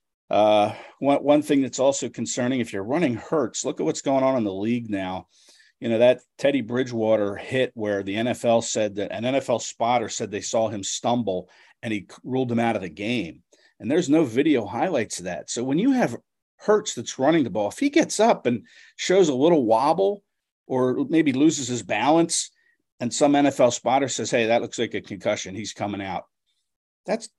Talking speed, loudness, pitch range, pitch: 200 wpm, -23 LUFS, 105-140 Hz, 120 Hz